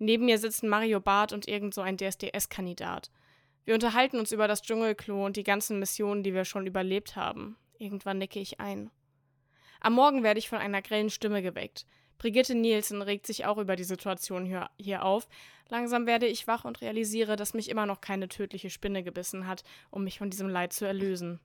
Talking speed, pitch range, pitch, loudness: 195 wpm, 190-220 Hz, 200 Hz, -30 LUFS